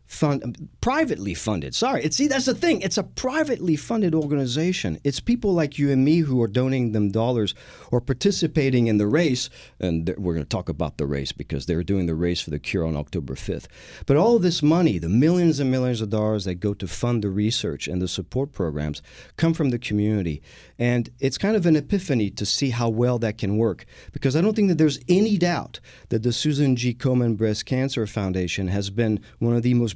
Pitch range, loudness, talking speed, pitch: 100-155 Hz, -23 LUFS, 220 wpm, 120 Hz